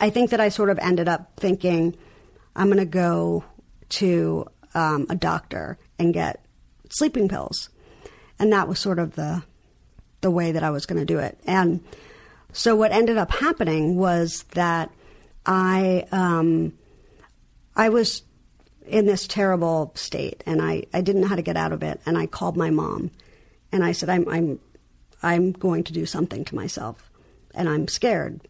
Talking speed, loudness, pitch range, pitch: 175 wpm, -23 LUFS, 160-195 Hz, 175 Hz